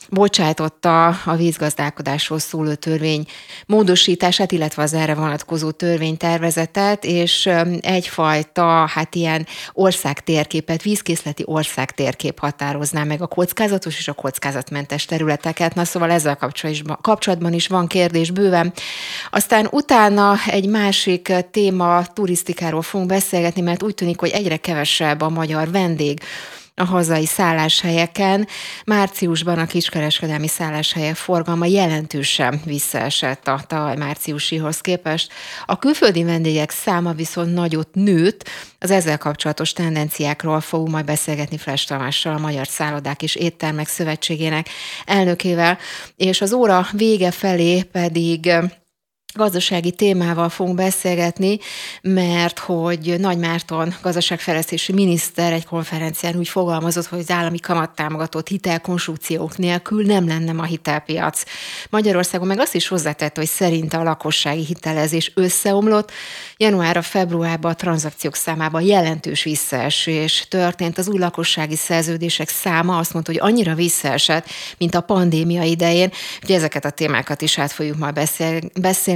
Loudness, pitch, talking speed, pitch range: -18 LUFS, 170 Hz, 125 wpm, 155-180 Hz